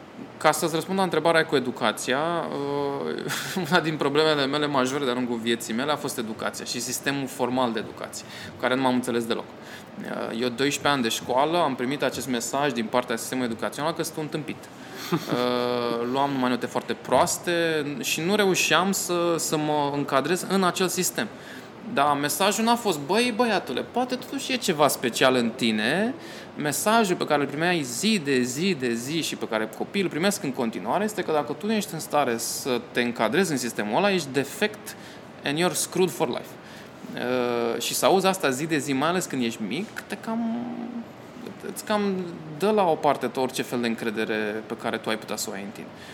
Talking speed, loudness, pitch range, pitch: 190 wpm, -25 LUFS, 125-180 Hz, 145 Hz